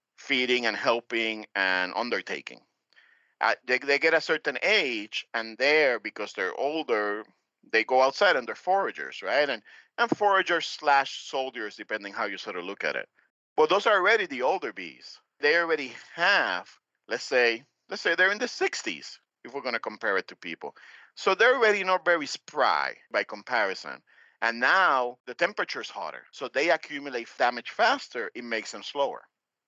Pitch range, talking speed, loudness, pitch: 115-190 Hz, 175 wpm, -26 LUFS, 135 Hz